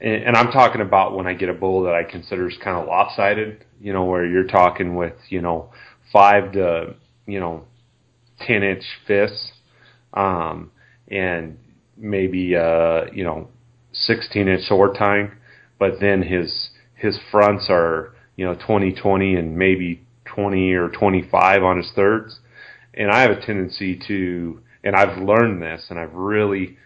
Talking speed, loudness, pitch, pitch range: 160 wpm, -19 LUFS, 100 Hz, 90-110 Hz